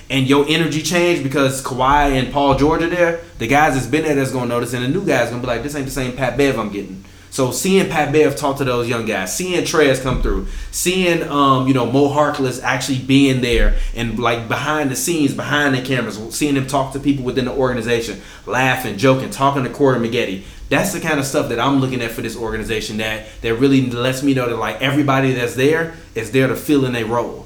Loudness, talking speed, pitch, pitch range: -17 LUFS, 235 wpm, 130 Hz, 120-145 Hz